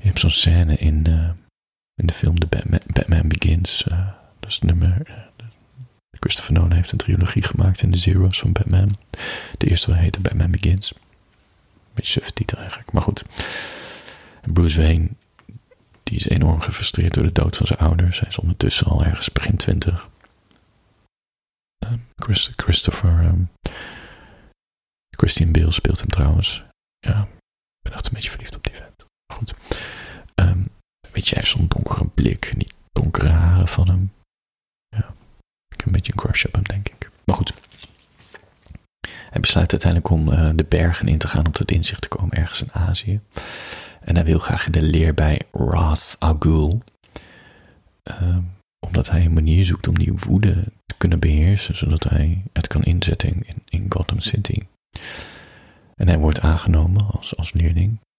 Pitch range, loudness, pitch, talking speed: 85-100 Hz, -20 LUFS, 90 Hz, 170 wpm